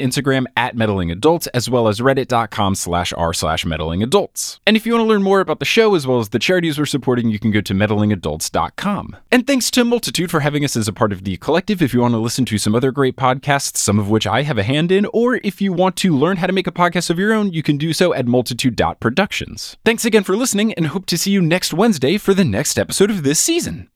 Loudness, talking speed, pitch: -17 LUFS, 255 wpm, 145 Hz